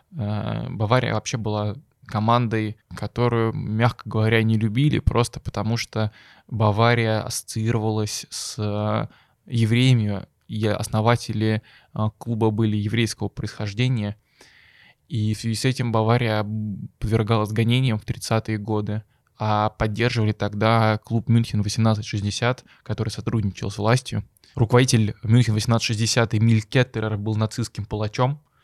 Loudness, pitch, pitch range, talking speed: -23 LUFS, 110 Hz, 105-120 Hz, 105 wpm